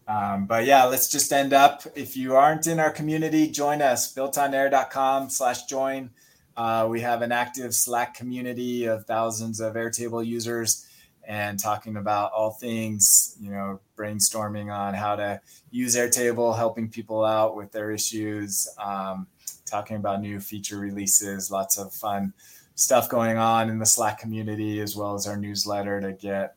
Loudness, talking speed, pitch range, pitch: -24 LUFS, 165 wpm, 105-125 Hz, 110 Hz